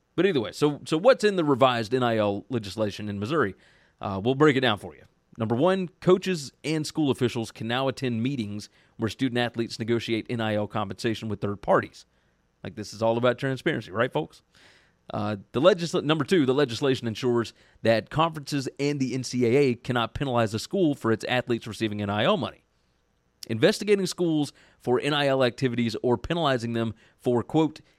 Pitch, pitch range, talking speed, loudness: 120 Hz, 110-145 Hz, 170 wpm, -26 LUFS